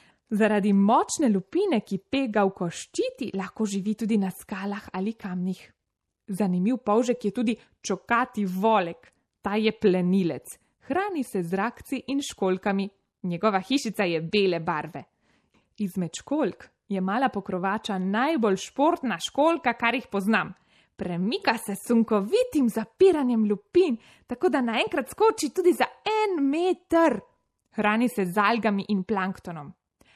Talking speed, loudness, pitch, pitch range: 125 wpm, -26 LUFS, 215 Hz, 195-255 Hz